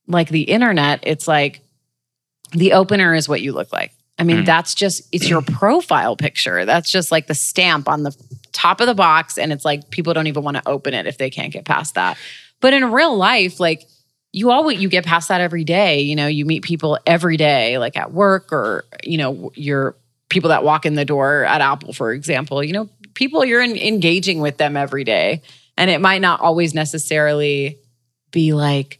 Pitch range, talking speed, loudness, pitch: 145-180 Hz, 210 wpm, -16 LUFS, 160 Hz